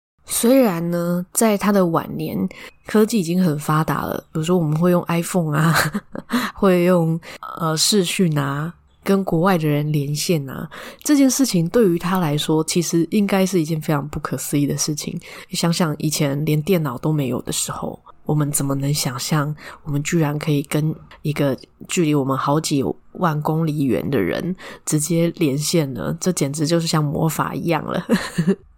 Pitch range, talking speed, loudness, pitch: 150-185 Hz, 265 characters per minute, -20 LUFS, 165 Hz